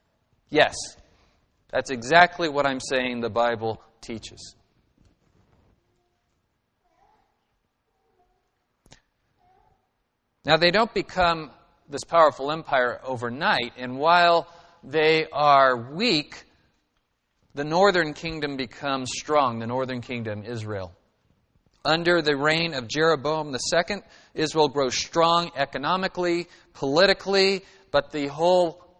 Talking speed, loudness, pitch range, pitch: 95 wpm, -23 LUFS, 125-170 Hz, 150 Hz